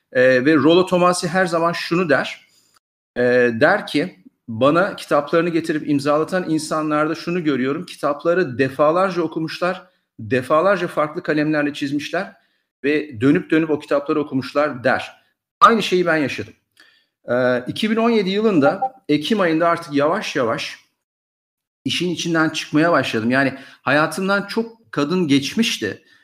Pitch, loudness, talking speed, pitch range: 155 Hz, -19 LUFS, 120 wpm, 145-180 Hz